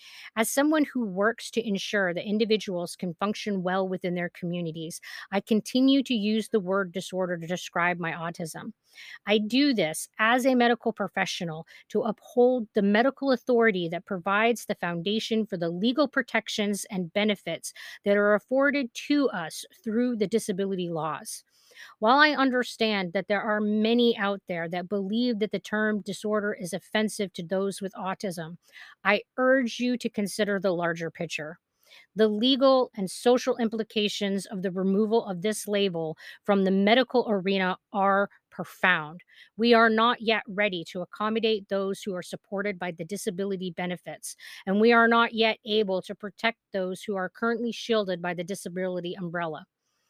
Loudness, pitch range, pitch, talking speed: -26 LUFS, 185-230 Hz, 205 Hz, 160 wpm